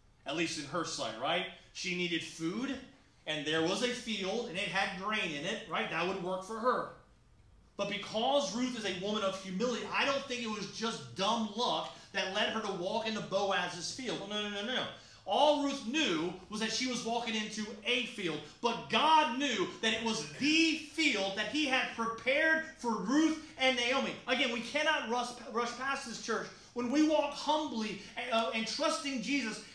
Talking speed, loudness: 200 wpm, -33 LUFS